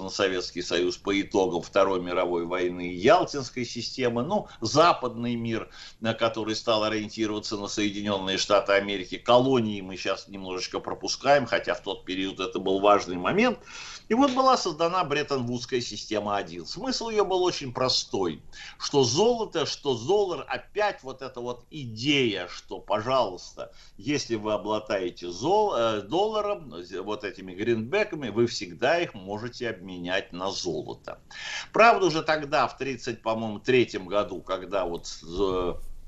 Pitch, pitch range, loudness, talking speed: 115 Hz, 100-145 Hz, -26 LUFS, 135 wpm